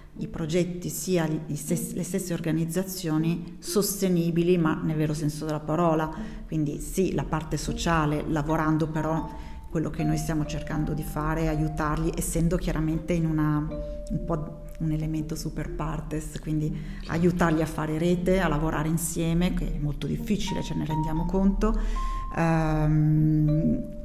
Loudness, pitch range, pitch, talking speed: -27 LUFS, 155-175 Hz, 160 Hz, 135 wpm